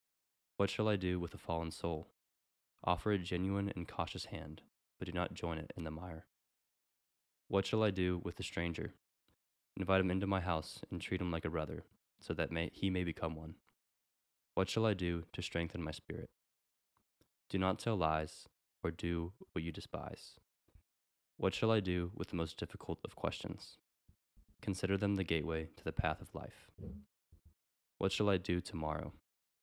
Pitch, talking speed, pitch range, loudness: 85 Hz, 180 wpm, 80-95 Hz, -39 LUFS